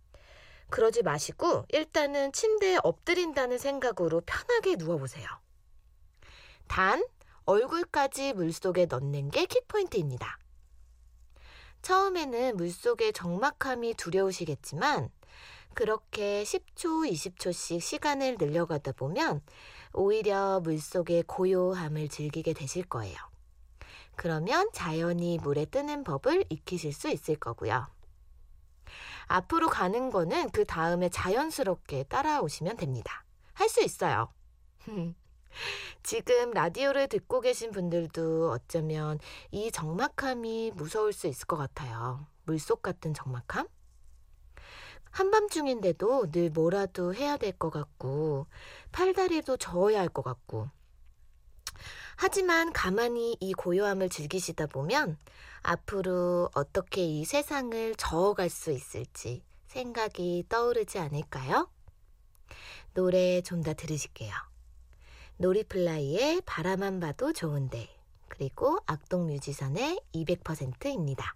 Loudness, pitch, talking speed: -31 LUFS, 175 Hz, 245 characters per minute